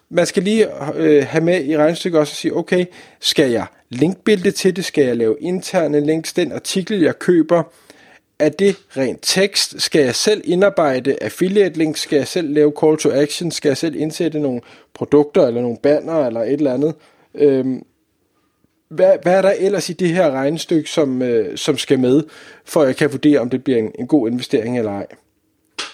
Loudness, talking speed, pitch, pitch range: -17 LUFS, 200 wpm, 155 Hz, 145-180 Hz